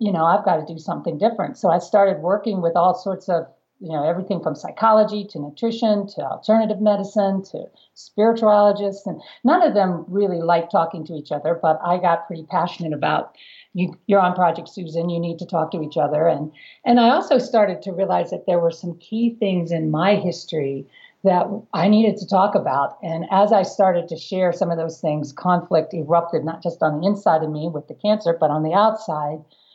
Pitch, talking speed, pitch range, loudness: 180 Hz, 210 wpm, 165-205 Hz, -20 LUFS